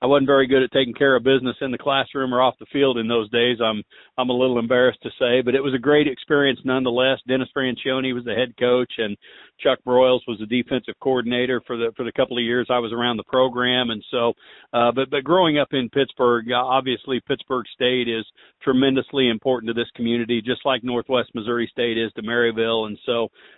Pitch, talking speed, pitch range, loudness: 125 Hz, 220 wpm, 120-130 Hz, -21 LUFS